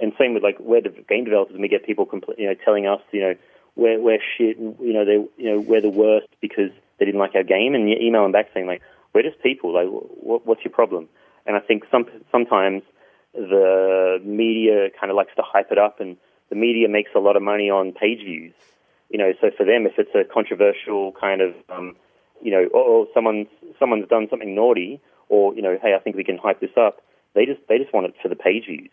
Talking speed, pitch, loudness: 245 wpm, 110 Hz, -20 LUFS